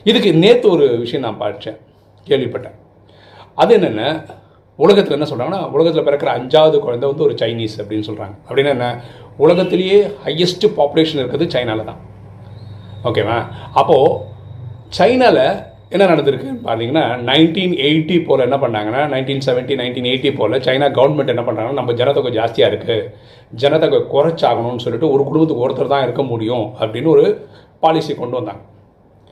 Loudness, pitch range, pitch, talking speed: -15 LUFS, 115-170 Hz, 140 Hz, 135 wpm